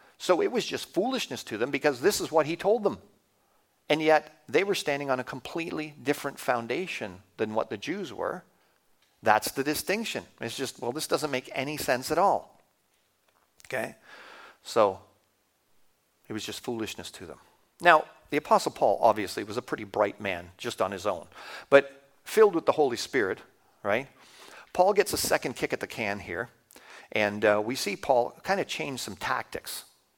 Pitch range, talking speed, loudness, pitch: 105-155 Hz, 180 wpm, -28 LUFS, 135 Hz